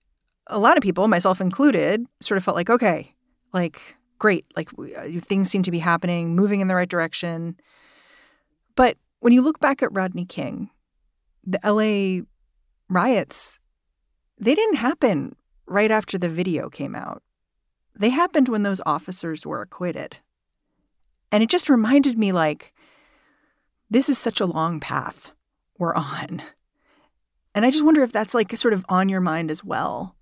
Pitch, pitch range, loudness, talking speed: 190 Hz, 165-235 Hz, -21 LUFS, 160 wpm